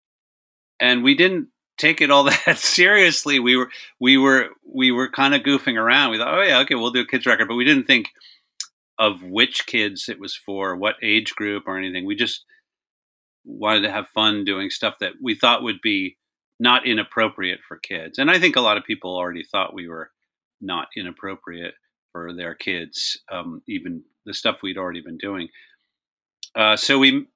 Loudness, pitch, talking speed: -18 LUFS, 130 Hz, 190 wpm